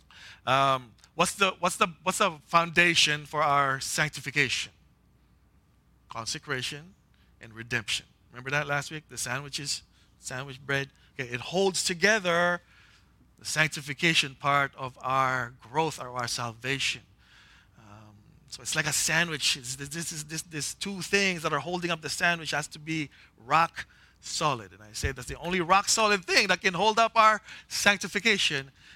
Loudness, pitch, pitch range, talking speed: -27 LUFS, 145 Hz, 125-175 Hz, 155 wpm